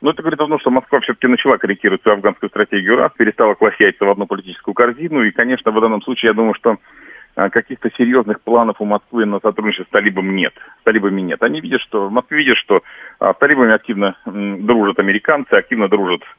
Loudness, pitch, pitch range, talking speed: -15 LUFS, 115 Hz, 100-125 Hz, 200 wpm